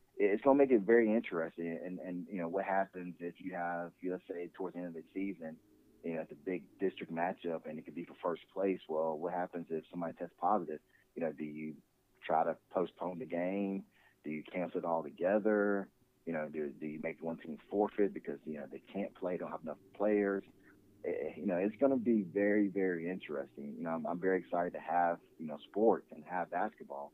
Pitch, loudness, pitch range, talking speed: 90 Hz, -36 LUFS, 80-100 Hz, 225 wpm